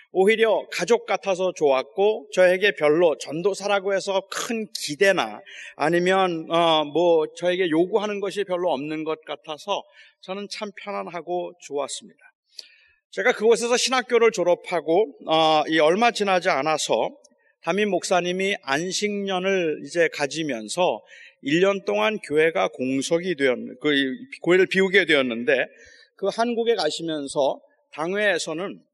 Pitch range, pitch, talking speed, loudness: 160-210 Hz, 185 Hz, 280 characters per minute, -22 LUFS